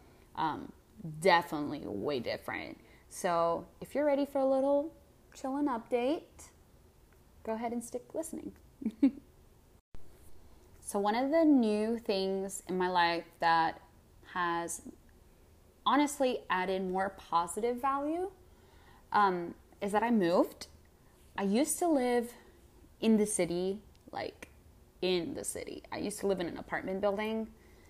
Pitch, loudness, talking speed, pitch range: 210 Hz, -32 LUFS, 125 wpm, 180-265 Hz